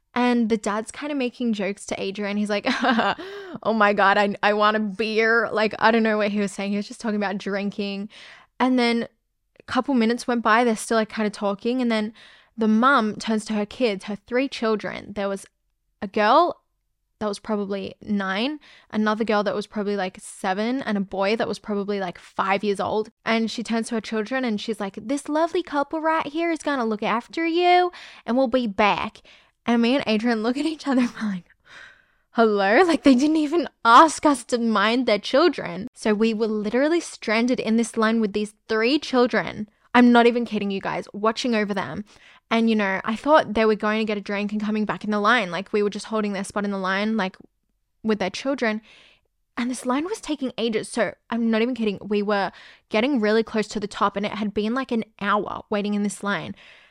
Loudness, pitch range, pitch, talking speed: -22 LUFS, 205-245 Hz, 220 Hz, 220 wpm